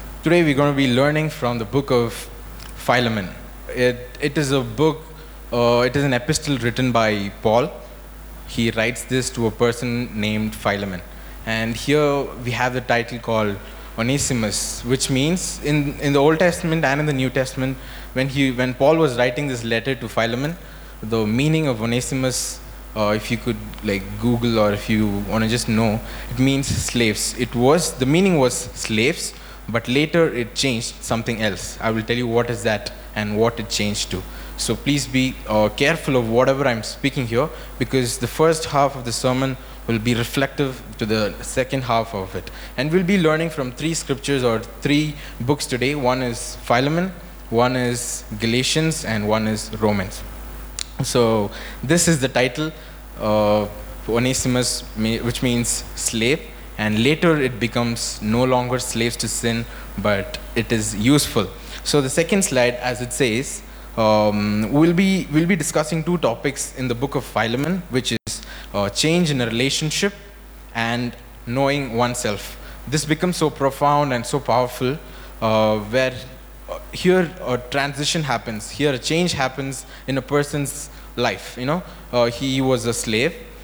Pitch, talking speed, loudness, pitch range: 125 Hz, 170 wpm, -20 LUFS, 115-140 Hz